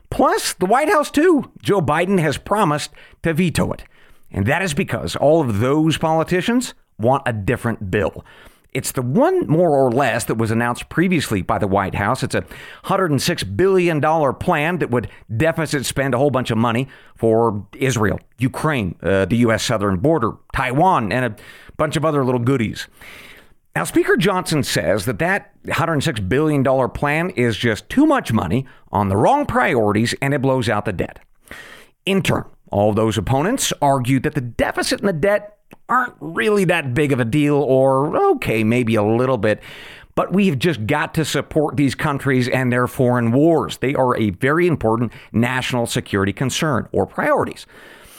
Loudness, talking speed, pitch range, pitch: -18 LUFS, 175 wpm, 115-160 Hz, 135 Hz